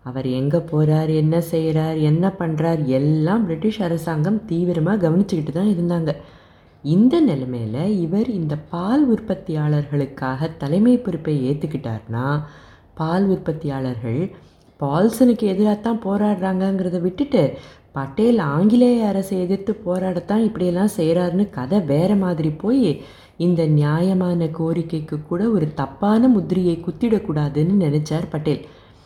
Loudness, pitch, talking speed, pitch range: -20 LUFS, 170 Hz, 105 wpm, 150-200 Hz